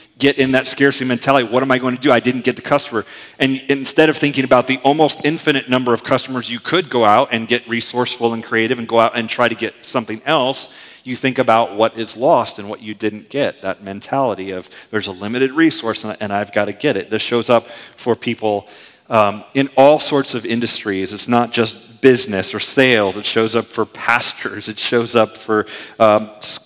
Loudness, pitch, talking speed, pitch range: -16 LUFS, 120 Hz, 215 wpm, 110-130 Hz